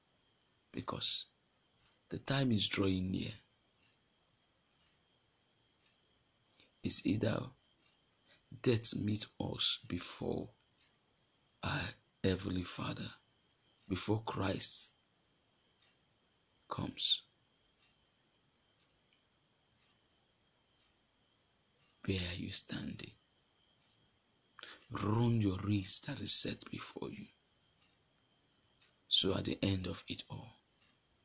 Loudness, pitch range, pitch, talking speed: -32 LUFS, 95-115 Hz, 105 Hz, 70 wpm